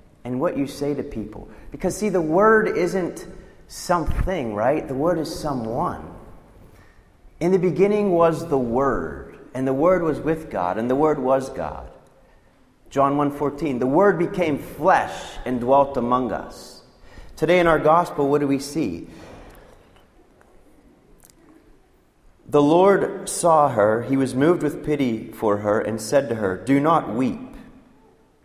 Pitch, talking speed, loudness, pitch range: 145 Hz, 150 wpm, -21 LUFS, 125-175 Hz